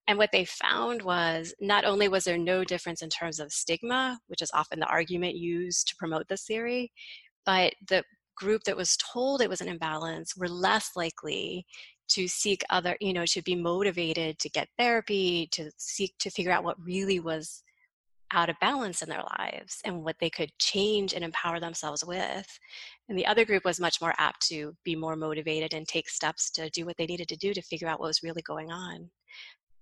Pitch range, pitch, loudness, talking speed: 165-195 Hz, 175 Hz, -29 LUFS, 205 wpm